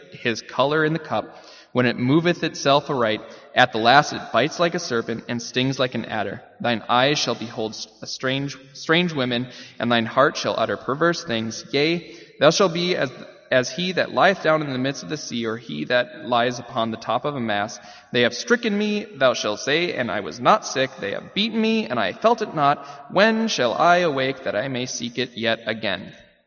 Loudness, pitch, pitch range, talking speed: -22 LUFS, 130 Hz, 120-165 Hz, 220 wpm